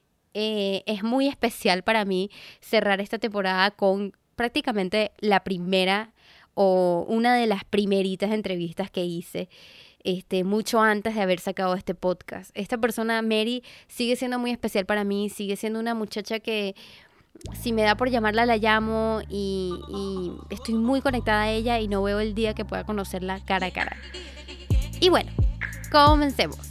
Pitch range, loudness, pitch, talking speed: 190-225 Hz, -25 LUFS, 210 Hz, 160 wpm